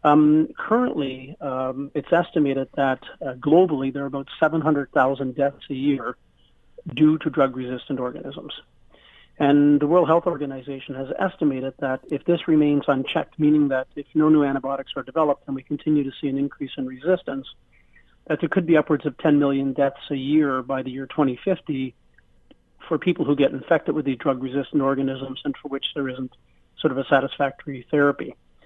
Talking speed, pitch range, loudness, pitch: 175 wpm, 135-155 Hz, -22 LUFS, 140 Hz